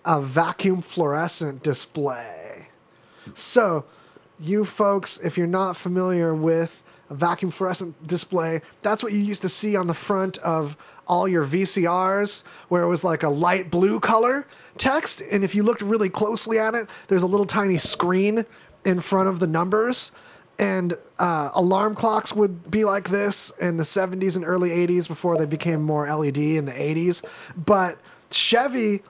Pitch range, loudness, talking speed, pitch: 170-205 Hz, -22 LUFS, 165 wpm, 185 Hz